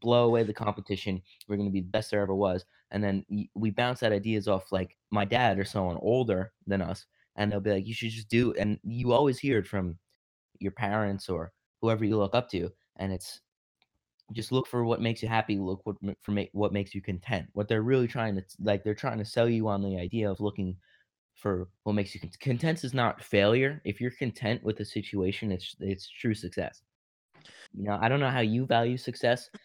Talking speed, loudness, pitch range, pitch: 225 wpm, -30 LUFS, 100-115 Hz, 105 Hz